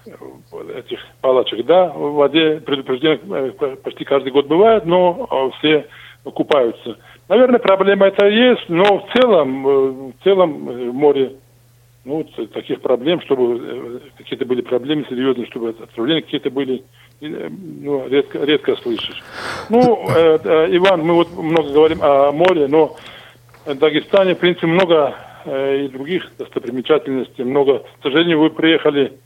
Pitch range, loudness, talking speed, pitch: 135-195 Hz, -16 LUFS, 125 wpm, 155 Hz